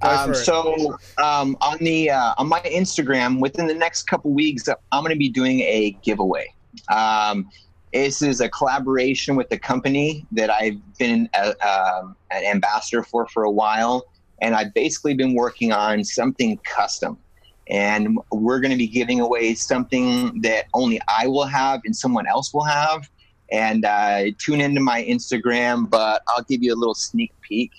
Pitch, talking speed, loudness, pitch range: 130 Hz, 175 wpm, -20 LUFS, 110-150 Hz